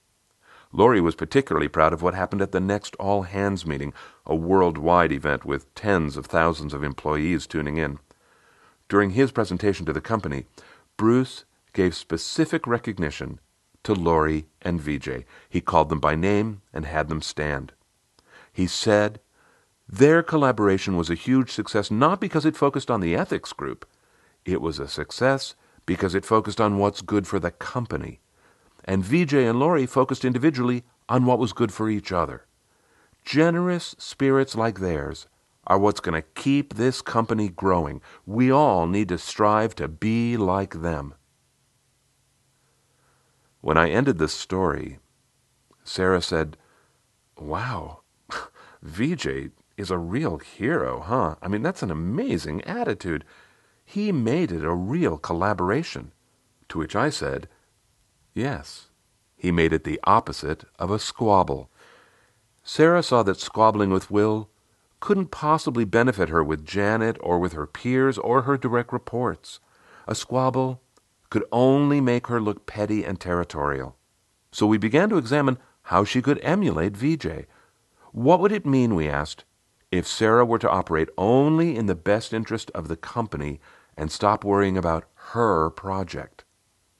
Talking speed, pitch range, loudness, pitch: 150 wpm, 85-125 Hz, -23 LUFS, 100 Hz